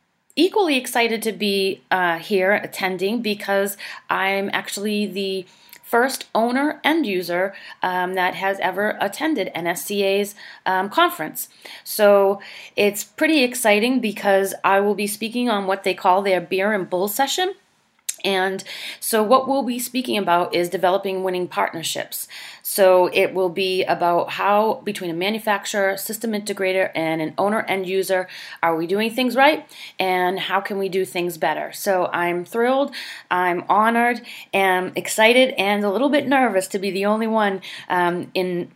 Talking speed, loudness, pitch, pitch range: 155 wpm, -20 LUFS, 195 Hz, 185-220 Hz